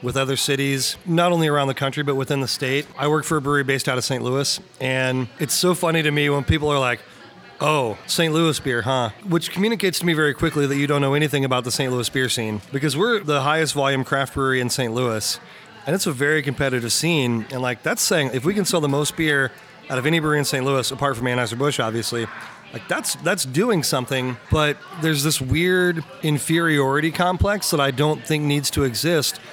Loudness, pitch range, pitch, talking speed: -21 LUFS, 130-155 Hz, 140 Hz, 225 wpm